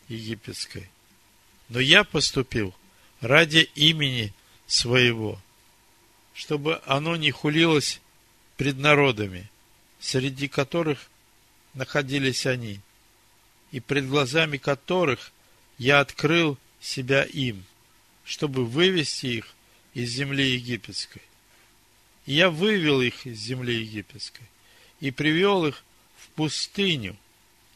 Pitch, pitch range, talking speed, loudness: 125 Hz, 115-145 Hz, 95 wpm, -23 LUFS